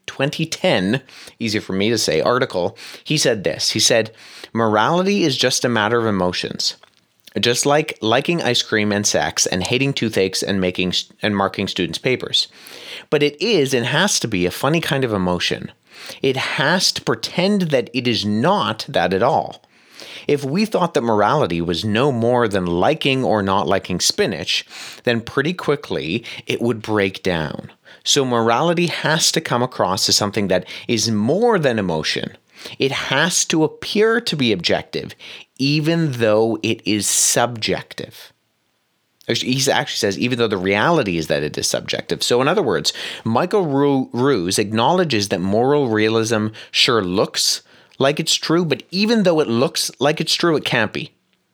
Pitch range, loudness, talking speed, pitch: 105-150 Hz, -18 LUFS, 165 wpm, 120 Hz